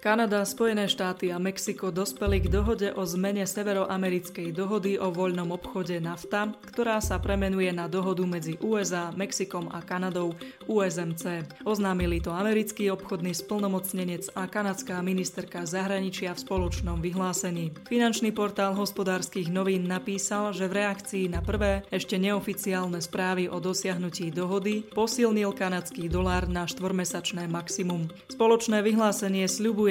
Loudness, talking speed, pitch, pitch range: -28 LUFS, 130 wpm, 190 Hz, 180-205 Hz